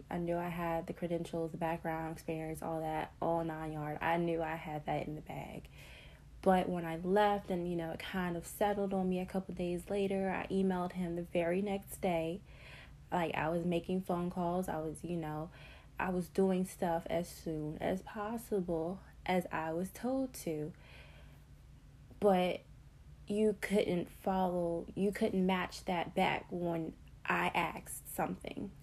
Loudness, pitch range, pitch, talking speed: -36 LUFS, 165-190 Hz, 175 Hz, 175 wpm